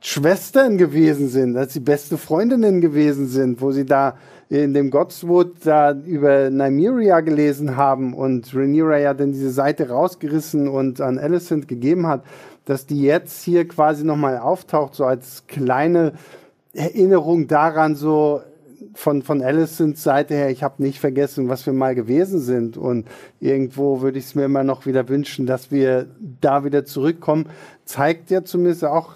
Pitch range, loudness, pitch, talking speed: 135-160 Hz, -18 LUFS, 145 Hz, 160 wpm